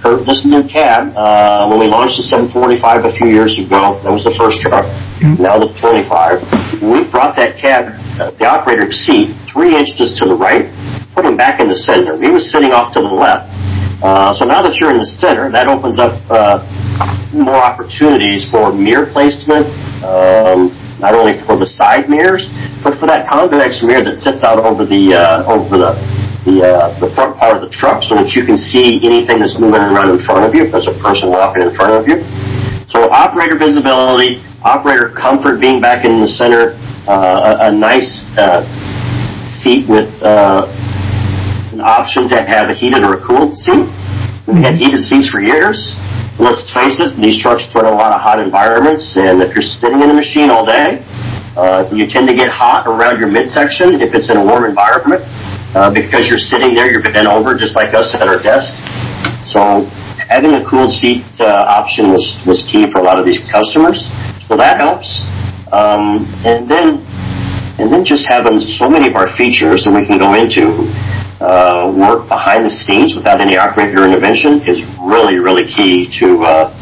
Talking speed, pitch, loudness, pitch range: 195 wpm, 110 Hz, -9 LUFS, 100-125 Hz